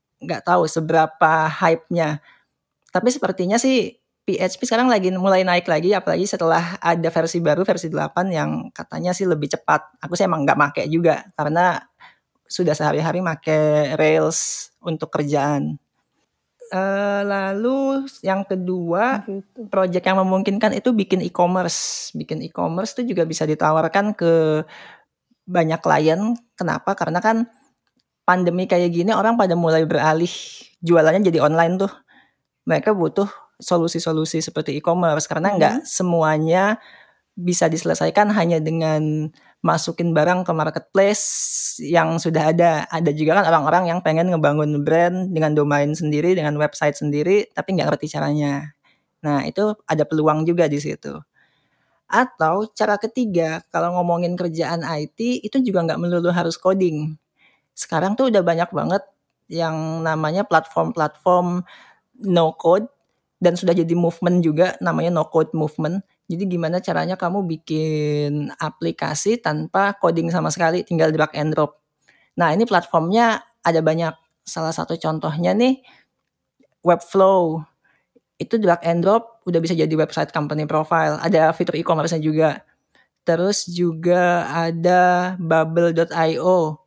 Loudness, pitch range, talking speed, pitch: -19 LUFS, 160-190 Hz, 130 wpm, 170 Hz